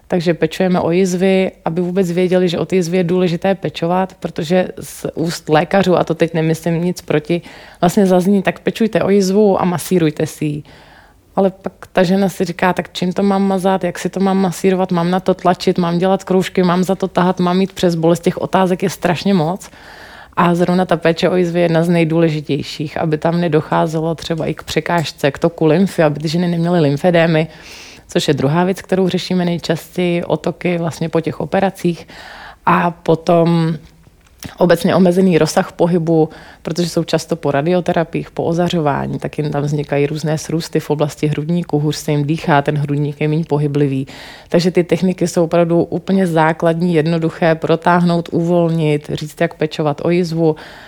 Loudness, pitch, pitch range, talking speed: -16 LUFS, 170 Hz, 160-185 Hz, 180 wpm